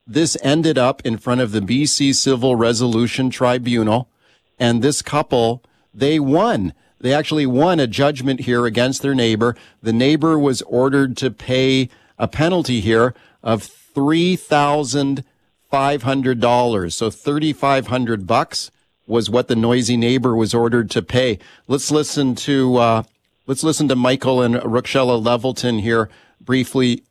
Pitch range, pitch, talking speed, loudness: 120-140 Hz, 125 Hz, 150 wpm, -17 LUFS